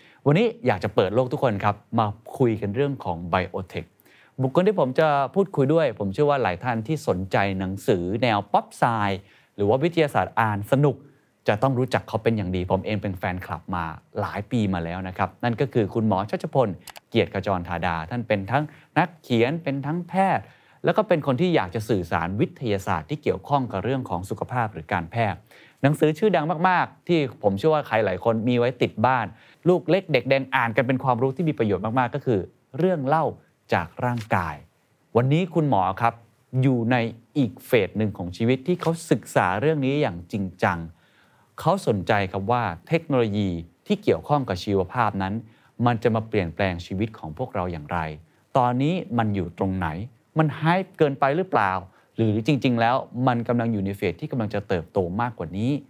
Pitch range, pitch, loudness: 100-140 Hz, 120 Hz, -24 LUFS